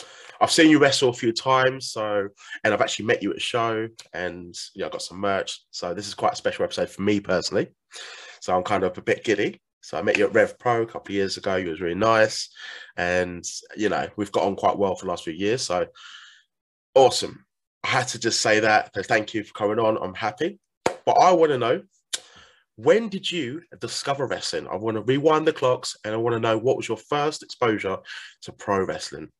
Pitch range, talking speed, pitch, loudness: 105-150 Hz, 230 wpm, 115 Hz, -23 LUFS